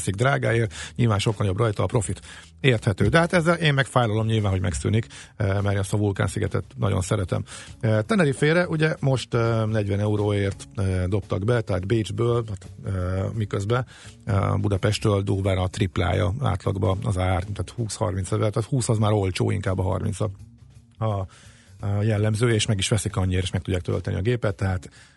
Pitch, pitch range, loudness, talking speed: 105 Hz, 100-115 Hz, -24 LUFS, 155 wpm